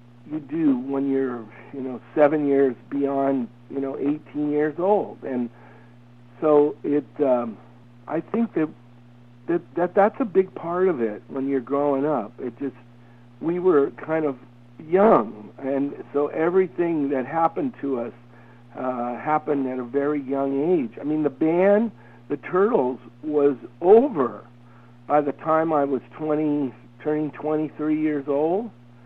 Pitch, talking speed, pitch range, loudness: 140 Hz, 150 wpm, 120-155 Hz, -23 LUFS